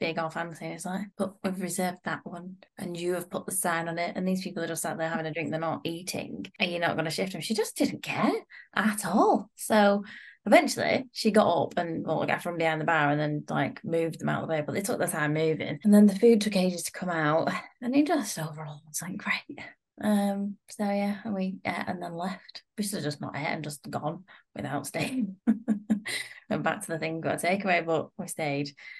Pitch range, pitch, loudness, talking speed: 165-210 Hz, 180 Hz, -28 LUFS, 245 wpm